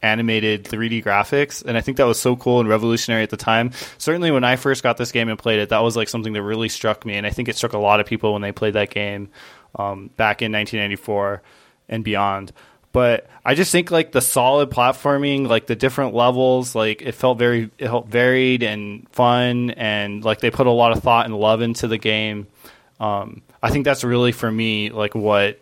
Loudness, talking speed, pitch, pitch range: -19 LUFS, 225 wpm, 115 Hz, 105-125 Hz